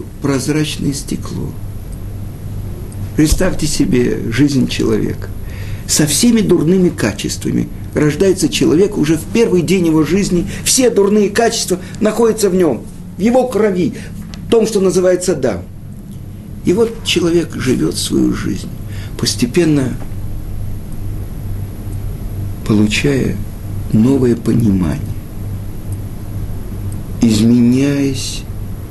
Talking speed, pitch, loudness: 90 wpm, 110 Hz, -15 LUFS